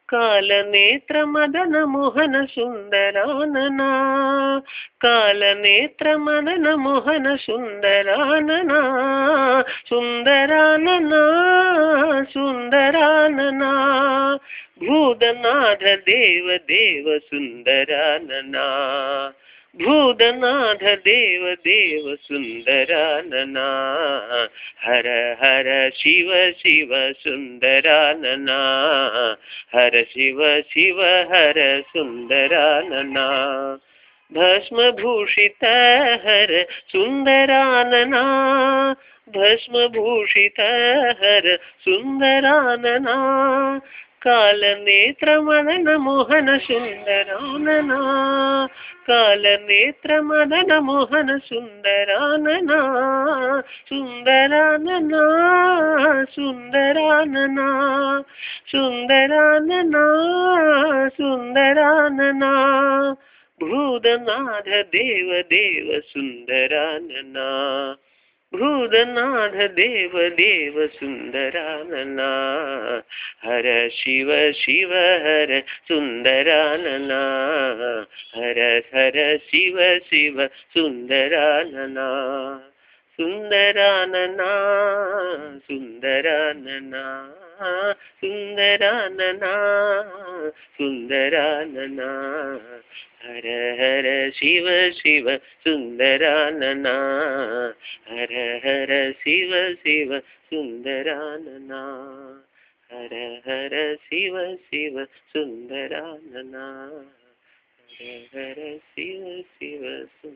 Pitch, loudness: 200 Hz, -17 LUFS